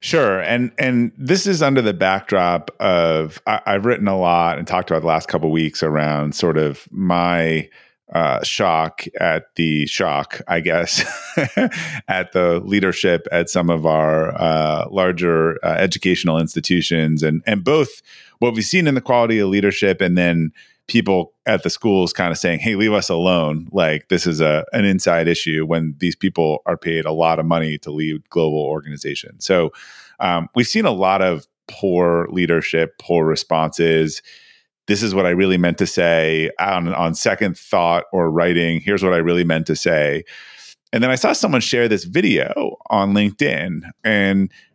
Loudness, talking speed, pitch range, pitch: -18 LUFS, 175 wpm, 80-100 Hz, 85 Hz